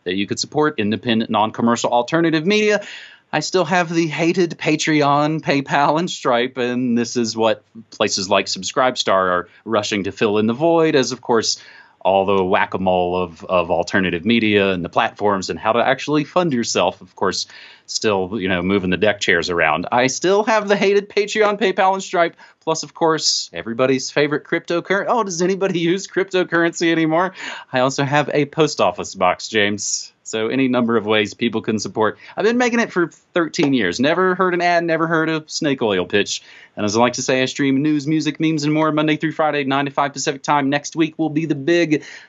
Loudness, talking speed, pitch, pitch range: -18 LUFS, 205 wpm, 150 Hz, 115-170 Hz